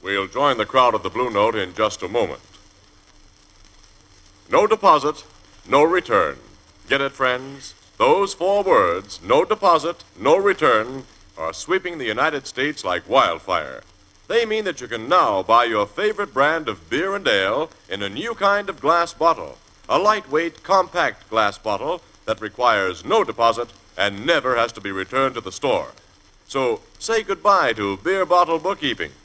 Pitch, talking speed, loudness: 140 Hz, 160 wpm, -20 LUFS